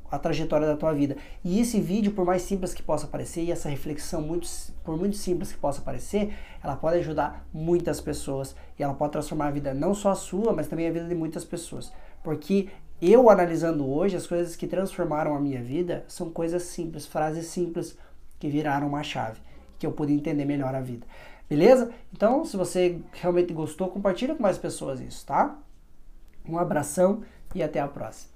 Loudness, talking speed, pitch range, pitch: -27 LUFS, 195 wpm, 150-180 Hz, 165 Hz